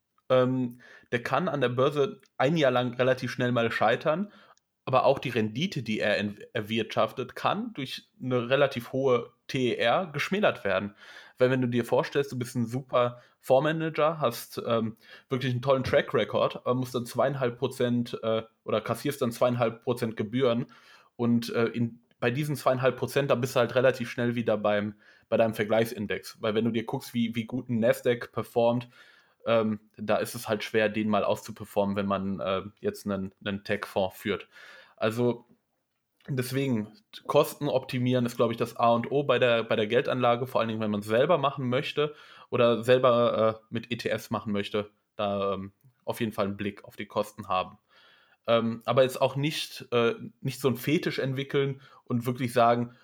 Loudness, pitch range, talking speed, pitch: -28 LUFS, 110-130 Hz, 180 wpm, 120 Hz